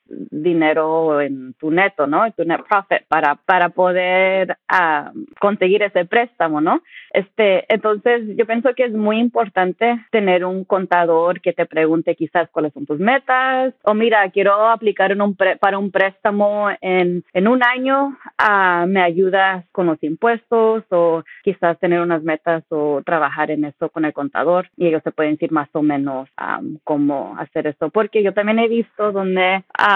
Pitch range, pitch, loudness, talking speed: 165-215 Hz, 185 Hz, -17 LUFS, 175 wpm